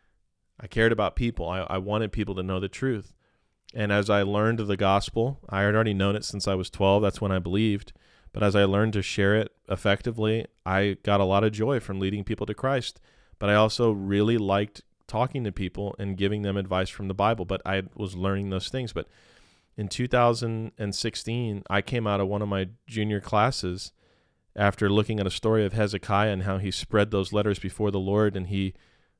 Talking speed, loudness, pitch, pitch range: 215 wpm, -26 LUFS, 100 Hz, 95-110 Hz